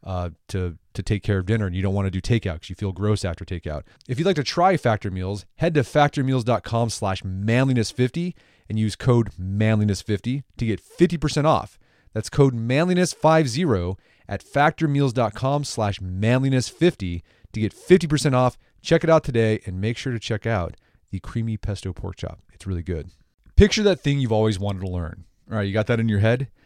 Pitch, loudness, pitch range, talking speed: 110 Hz, -22 LUFS, 95-135 Hz, 185 wpm